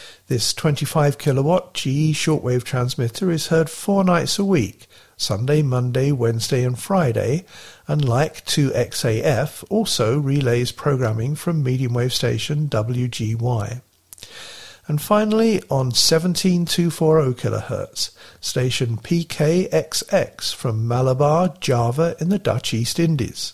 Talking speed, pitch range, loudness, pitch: 110 wpm, 120-160 Hz, -20 LUFS, 140 Hz